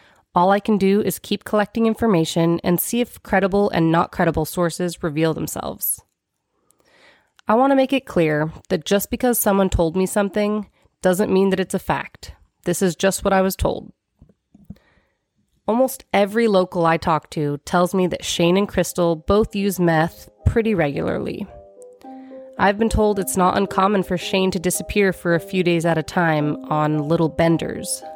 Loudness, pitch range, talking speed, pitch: -20 LUFS, 165-205 Hz, 175 wpm, 185 Hz